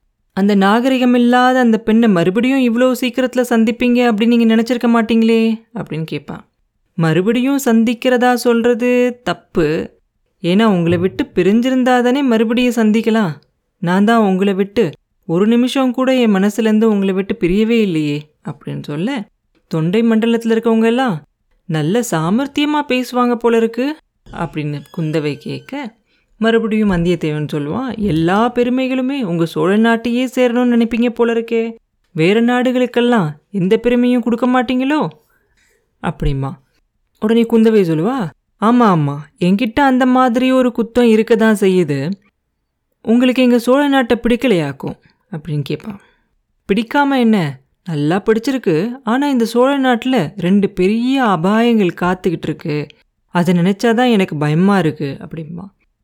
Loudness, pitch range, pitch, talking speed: -15 LUFS, 180-245 Hz, 225 Hz, 120 wpm